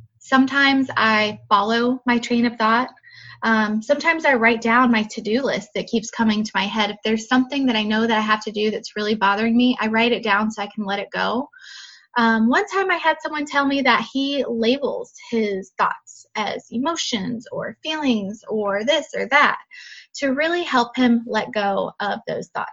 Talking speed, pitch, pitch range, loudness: 205 wpm, 235 Hz, 215-270 Hz, -20 LUFS